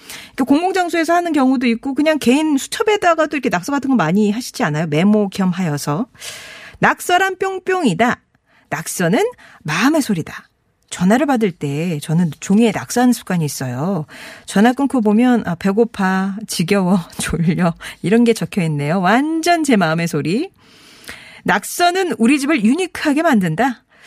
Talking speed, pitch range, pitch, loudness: 320 characters per minute, 180-290 Hz, 230 Hz, -17 LUFS